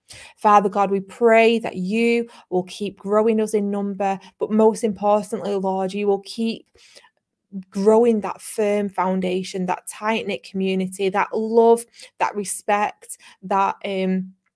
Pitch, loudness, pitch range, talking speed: 205 Hz, -21 LUFS, 190-220 Hz, 135 wpm